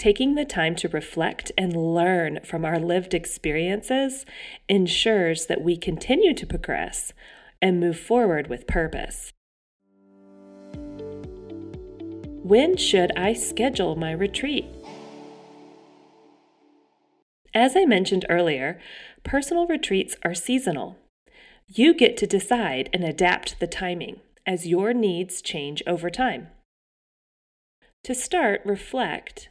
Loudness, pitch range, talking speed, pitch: -23 LUFS, 165-245 Hz, 110 wpm, 185 Hz